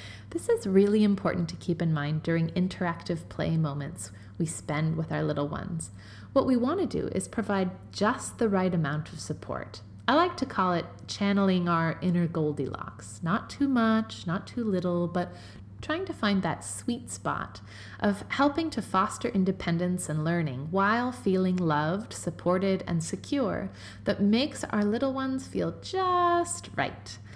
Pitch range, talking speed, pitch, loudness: 155-220 Hz, 160 wpm, 180 Hz, -29 LUFS